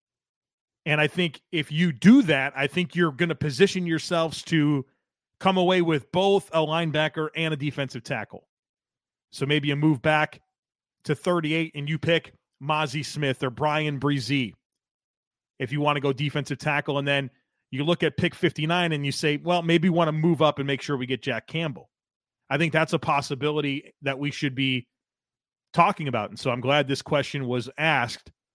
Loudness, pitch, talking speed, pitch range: -24 LUFS, 150 Hz, 190 wpm, 140-165 Hz